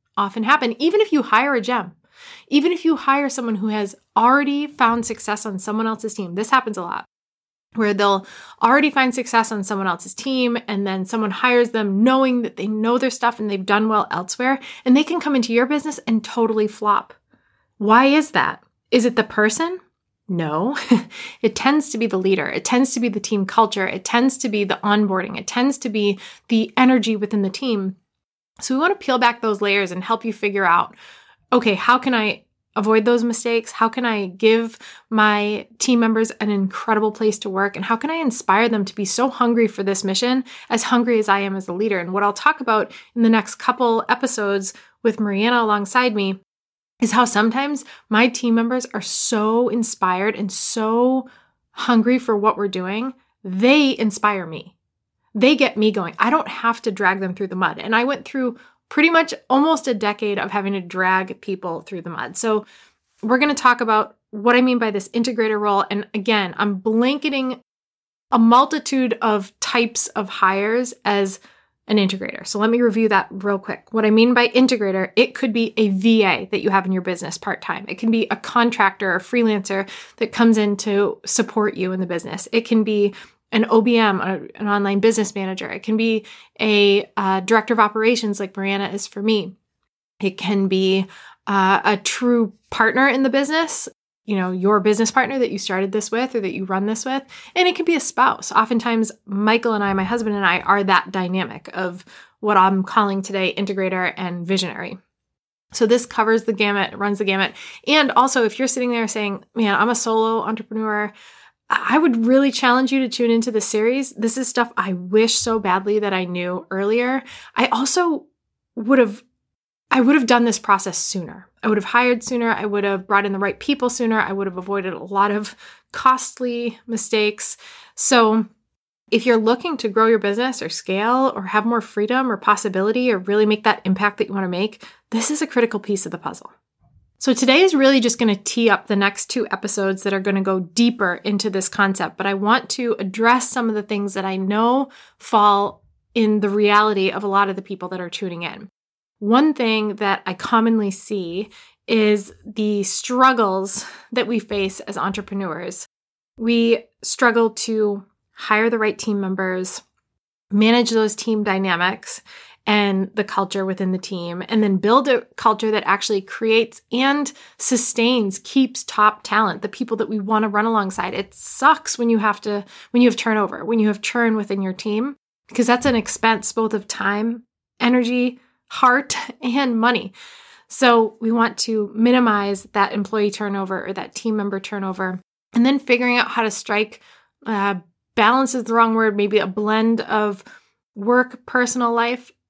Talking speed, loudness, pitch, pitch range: 195 wpm, -19 LUFS, 220 Hz, 200-240 Hz